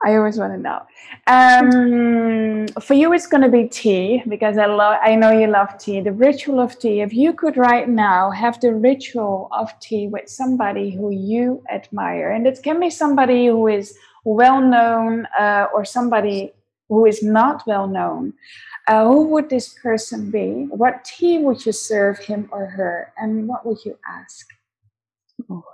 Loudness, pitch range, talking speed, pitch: -17 LUFS, 210-255 Hz, 180 wpm, 225 Hz